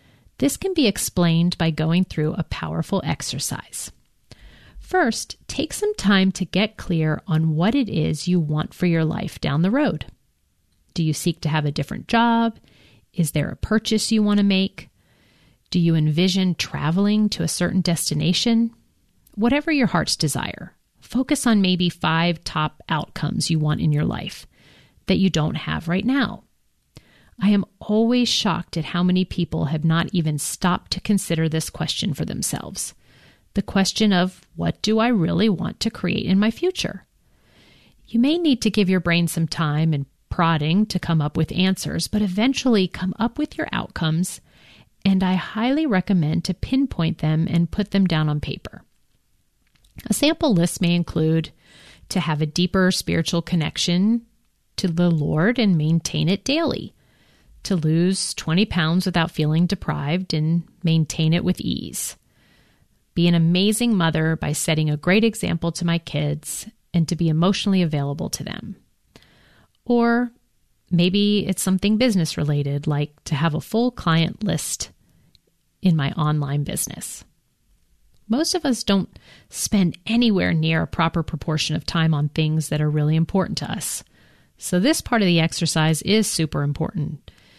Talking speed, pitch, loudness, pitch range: 160 wpm, 175 Hz, -21 LUFS, 160-205 Hz